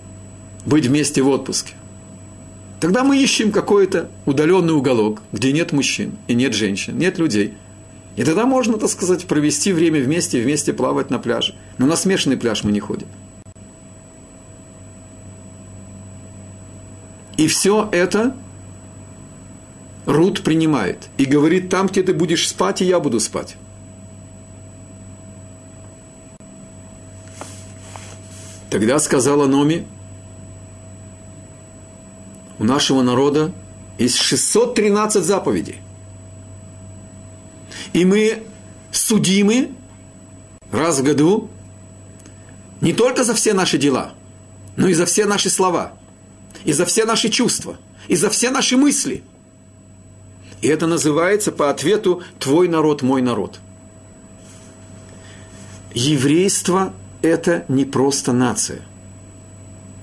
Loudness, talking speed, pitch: -17 LUFS, 105 wpm, 105 Hz